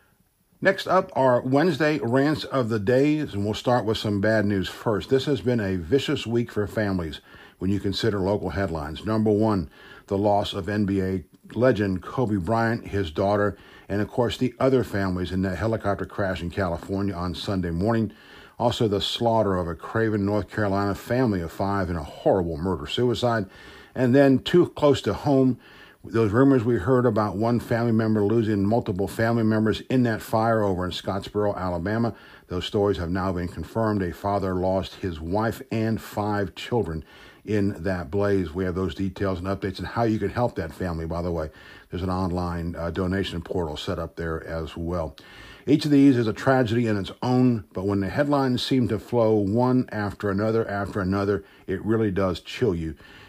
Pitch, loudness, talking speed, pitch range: 105 Hz, -24 LUFS, 185 wpm, 95-115 Hz